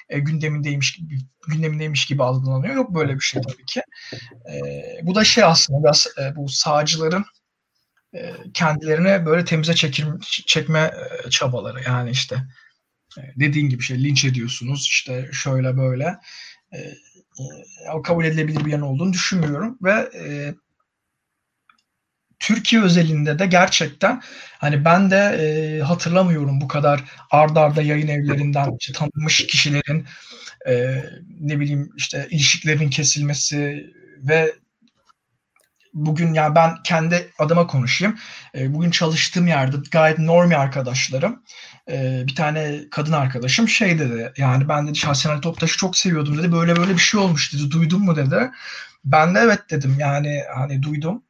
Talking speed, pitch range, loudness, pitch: 145 wpm, 140-170 Hz, -19 LUFS, 150 Hz